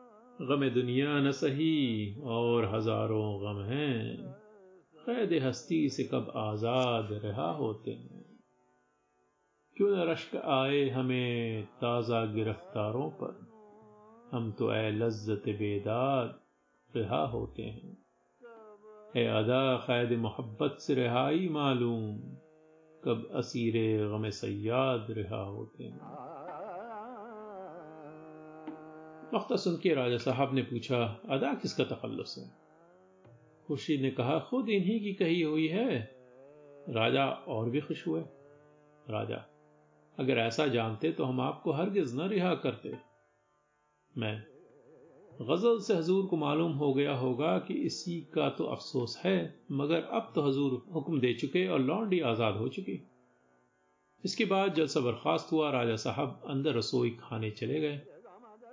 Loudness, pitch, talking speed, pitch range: -32 LUFS, 135 Hz, 120 wpm, 115-160 Hz